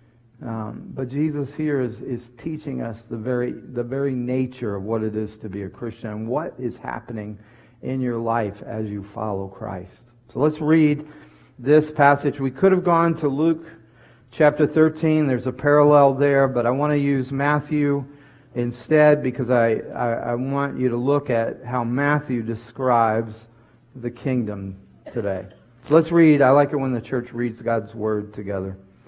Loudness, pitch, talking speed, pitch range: -22 LUFS, 125 Hz, 175 wpm, 115-145 Hz